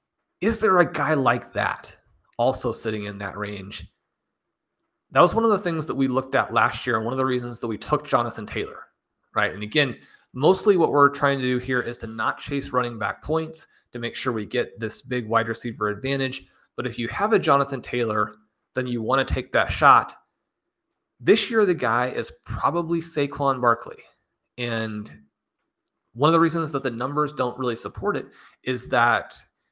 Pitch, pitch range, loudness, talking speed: 125 Hz, 110-140 Hz, -23 LUFS, 195 wpm